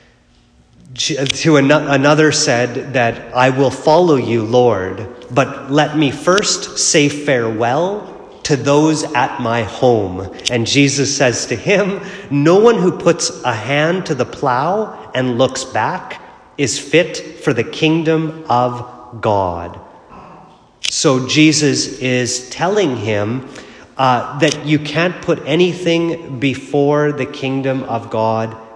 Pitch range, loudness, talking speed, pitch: 125-155 Hz, -15 LUFS, 125 wpm, 140 Hz